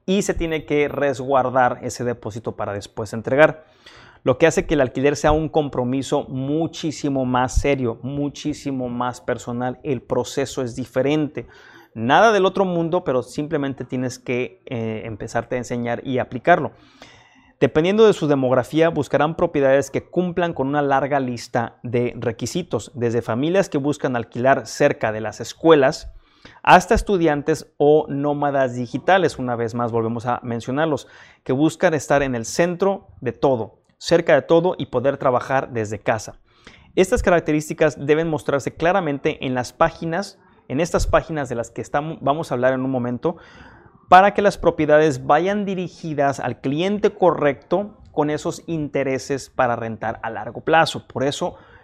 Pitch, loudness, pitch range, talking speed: 140 Hz, -20 LUFS, 125-160 Hz, 155 wpm